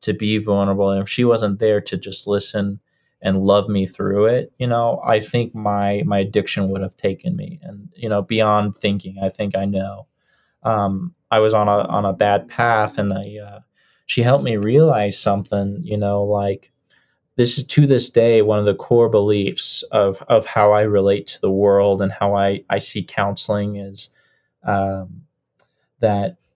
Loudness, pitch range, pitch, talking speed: -18 LUFS, 100-110 Hz, 105 Hz, 190 wpm